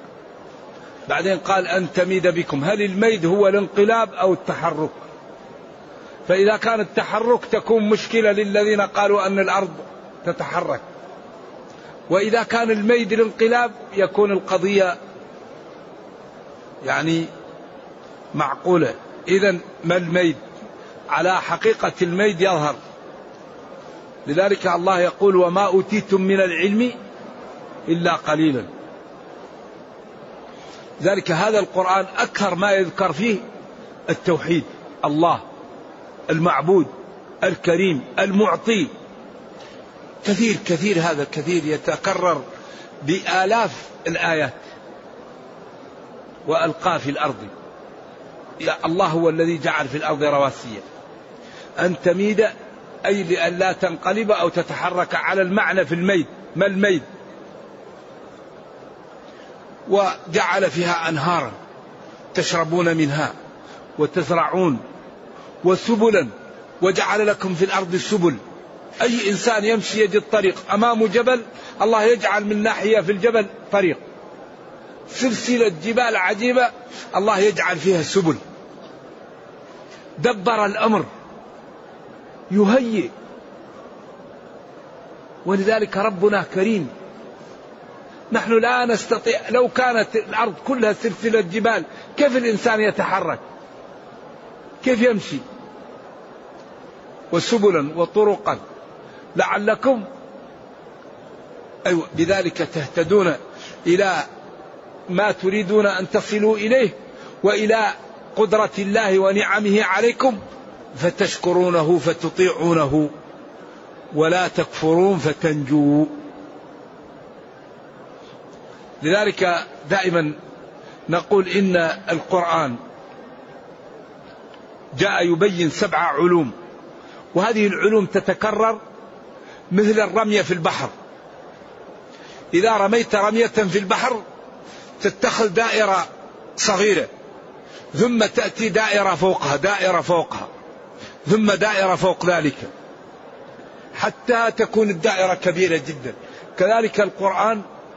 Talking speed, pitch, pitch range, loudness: 85 wpm, 195 Hz, 175-220 Hz, -19 LUFS